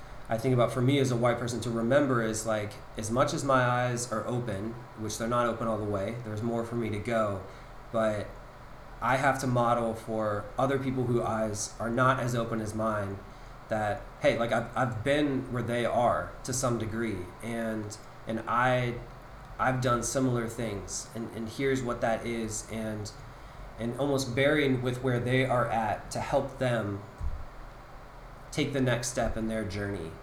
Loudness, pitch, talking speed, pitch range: -30 LUFS, 120 Hz, 185 wpm, 110-130 Hz